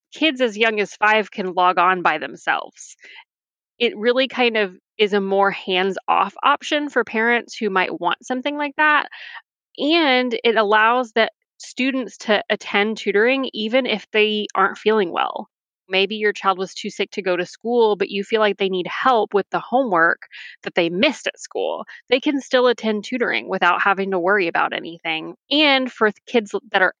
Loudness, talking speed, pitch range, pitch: -19 LUFS, 185 wpm, 195-255 Hz, 215 Hz